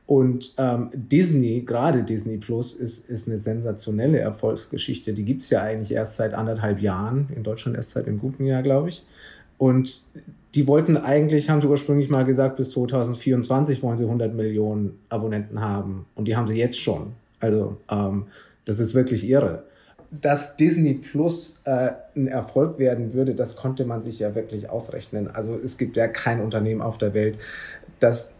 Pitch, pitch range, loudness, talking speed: 120 Hz, 110-135 Hz, -23 LUFS, 175 wpm